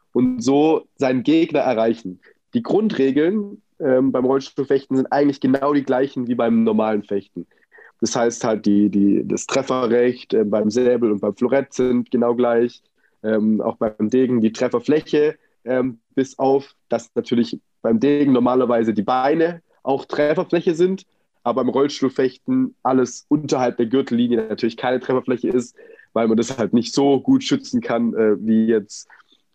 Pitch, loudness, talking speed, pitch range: 130 Hz, -19 LUFS, 155 wpm, 115-140 Hz